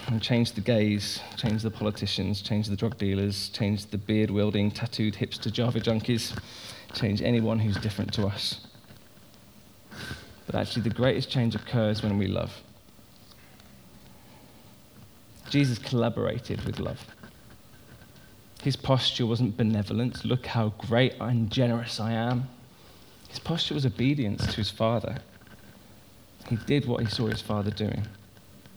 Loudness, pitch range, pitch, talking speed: -28 LUFS, 105-120 Hz, 110 Hz, 135 wpm